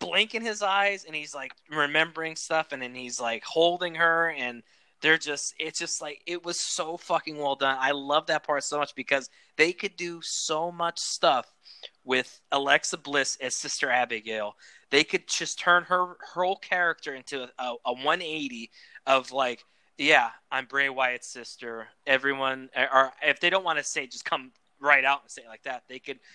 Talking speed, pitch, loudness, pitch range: 185 wpm, 145 Hz, -26 LUFS, 130-165 Hz